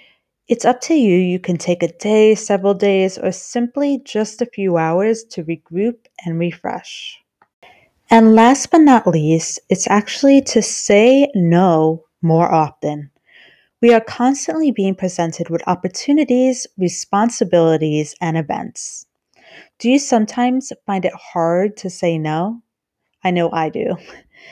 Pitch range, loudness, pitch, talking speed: 170-240 Hz, -16 LUFS, 195 Hz, 135 wpm